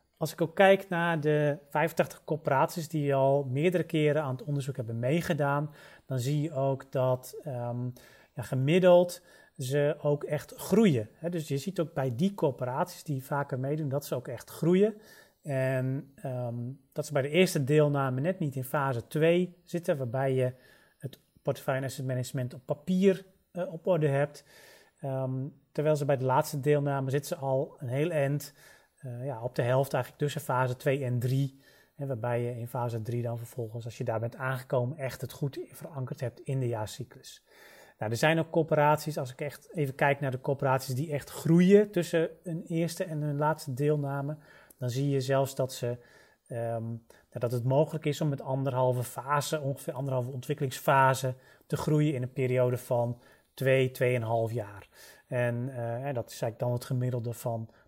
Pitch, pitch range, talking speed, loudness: 140 Hz, 130-155 Hz, 180 wpm, -30 LUFS